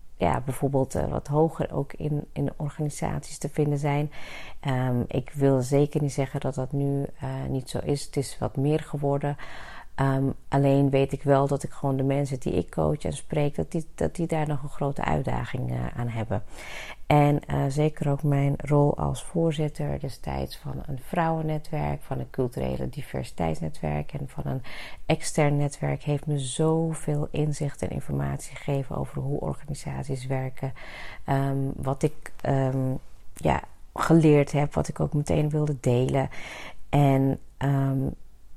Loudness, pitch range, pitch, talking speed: -27 LUFS, 130-150 Hz, 140 Hz, 160 wpm